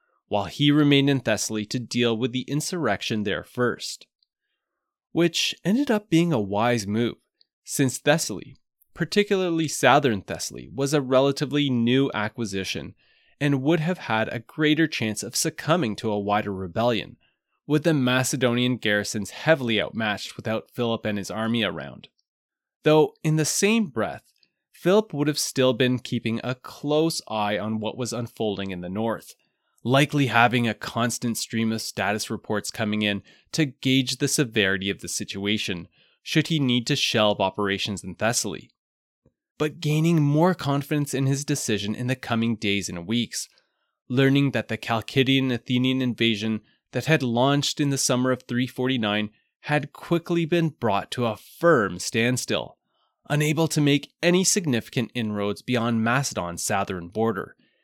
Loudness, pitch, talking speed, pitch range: -24 LUFS, 125 Hz, 150 wpm, 110-145 Hz